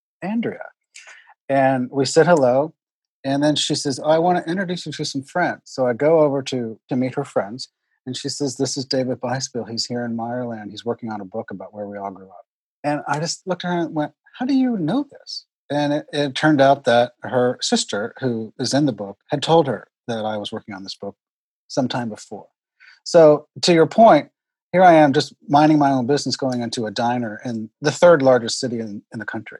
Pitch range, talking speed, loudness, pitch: 120-155 Hz, 225 wpm, -19 LUFS, 135 Hz